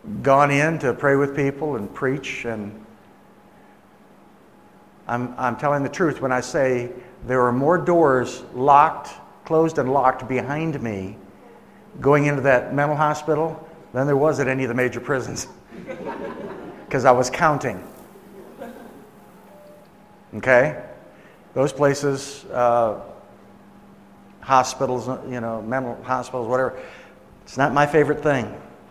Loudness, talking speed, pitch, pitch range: -21 LUFS, 125 wpm, 135 Hz, 125-150 Hz